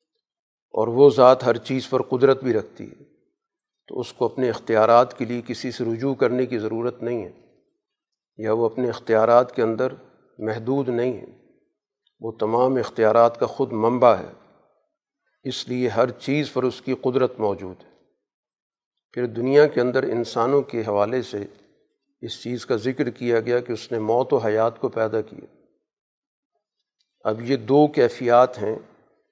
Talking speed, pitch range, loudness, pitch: 160 wpm, 115-130 Hz, -21 LUFS, 120 Hz